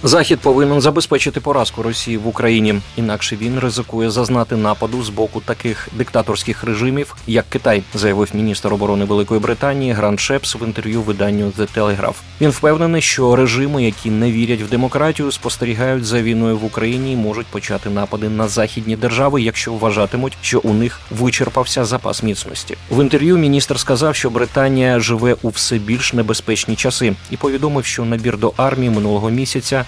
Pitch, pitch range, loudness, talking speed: 115 Hz, 110-130 Hz, -16 LUFS, 160 wpm